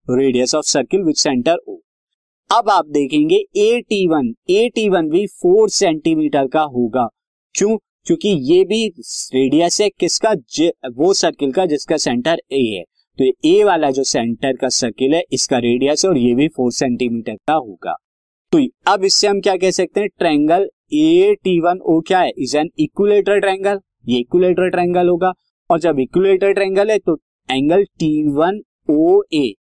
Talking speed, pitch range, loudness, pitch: 180 wpm, 150-225 Hz, -16 LUFS, 185 Hz